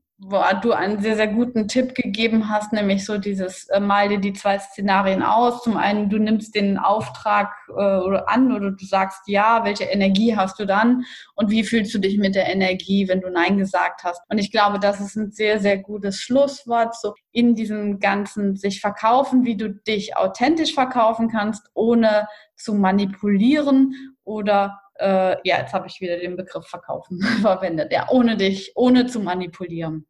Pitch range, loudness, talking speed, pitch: 195-225 Hz, -20 LUFS, 180 wpm, 205 Hz